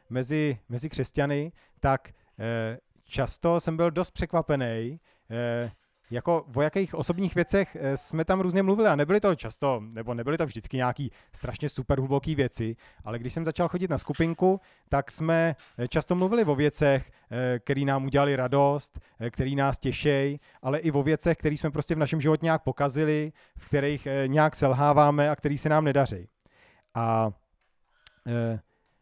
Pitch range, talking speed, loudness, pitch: 125-160 Hz, 165 wpm, -27 LUFS, 140 Hz